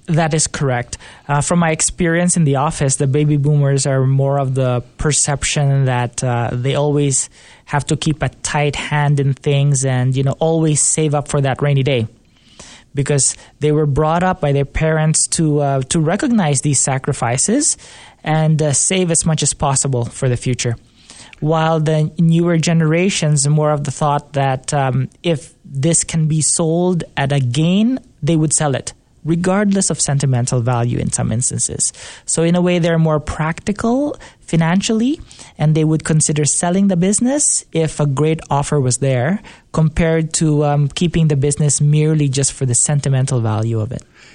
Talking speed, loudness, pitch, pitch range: 175 wpm, -16 LUFS, 150 Hz, 135-160 Hz